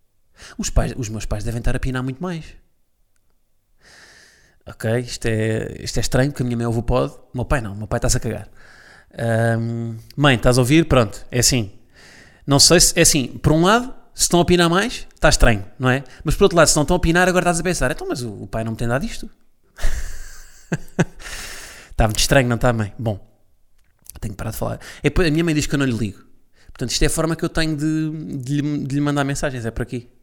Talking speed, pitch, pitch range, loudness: 240 wpm, 125 Hz, 115-150 Hz, -19 LUFS